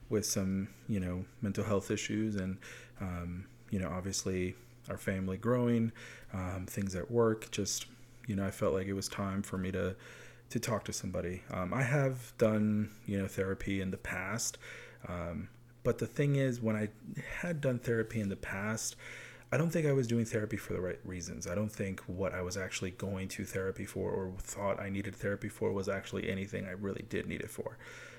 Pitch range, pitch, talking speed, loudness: 95-115 Hz, 100 Hz, 200 wpm, -36 LUFS